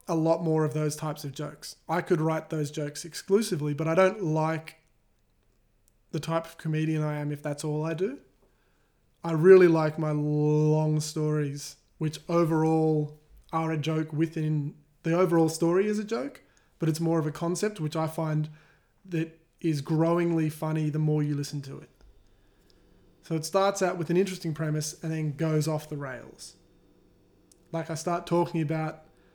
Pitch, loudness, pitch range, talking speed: 160 Hz, -28 LUFS, 150-165 Hz, 175 wpm